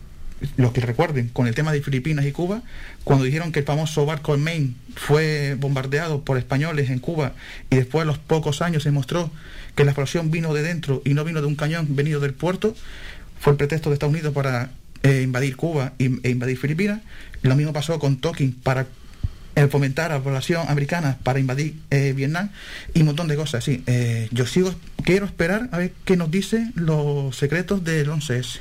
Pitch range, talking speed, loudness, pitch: 135-160 Hz, 200 wpm, -22 LUFS, 145 Hz